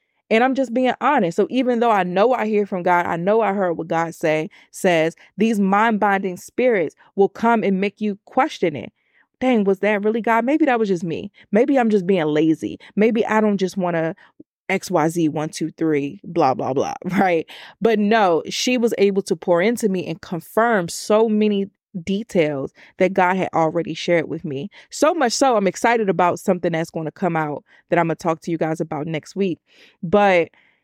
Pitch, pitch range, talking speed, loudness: 195 Hz, 170-225 Hz, 210 wpm, -20 LUFS